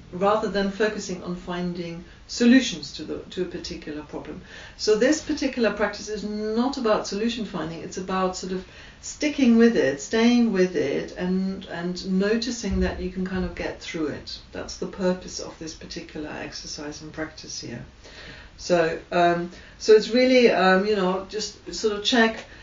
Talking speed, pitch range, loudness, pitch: 170 wpm, 175-215 Hz, -24 LUFS, 190 Hz